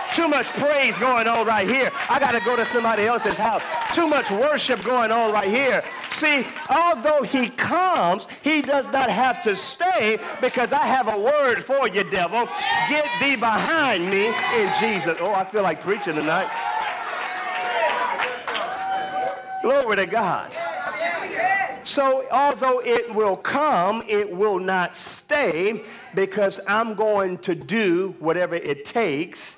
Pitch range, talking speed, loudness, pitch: 210-295 Hz, 145 wpm, -21 LUFS, 245 Hz